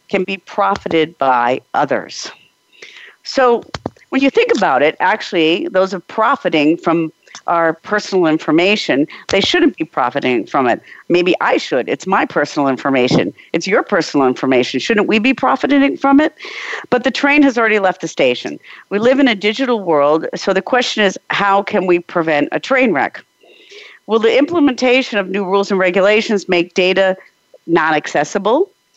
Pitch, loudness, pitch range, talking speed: 200 Hz, -14 LUFS, 170-265 Hz, 165 wpm